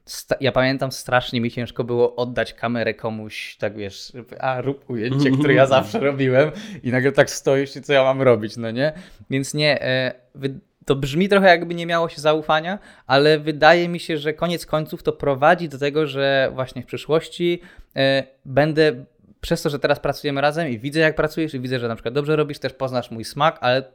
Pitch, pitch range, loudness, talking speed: 140 Hz, 130-155 Hz, -20 LUFS, 195 wpm